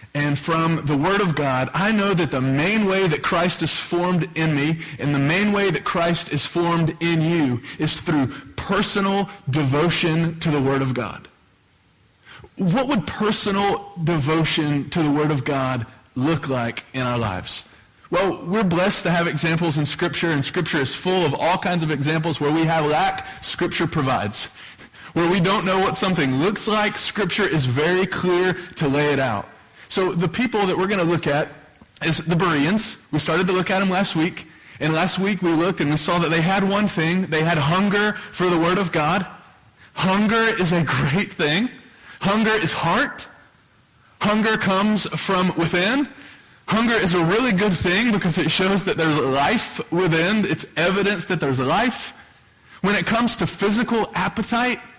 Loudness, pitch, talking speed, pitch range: -20 LUFS, 170 Hz, 180 wpm, 150-195 Hz